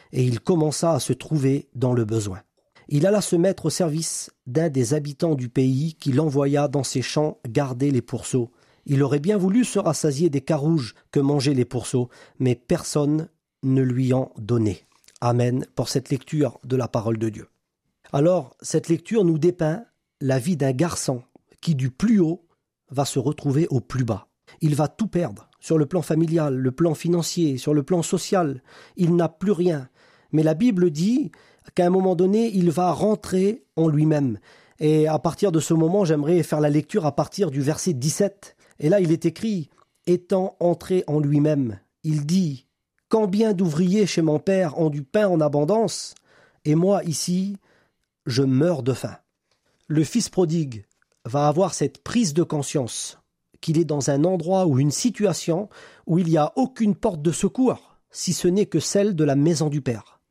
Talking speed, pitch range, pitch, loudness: 185 wpm, 140-180 Hz, 155 Hz, -22 LUFS